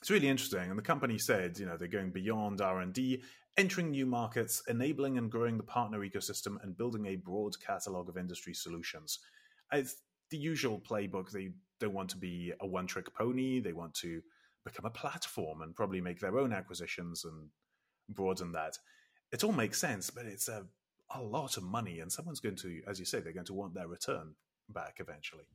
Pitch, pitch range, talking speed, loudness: 100 Hz, 90-125 Hz, 200 wpm, -38 LUFS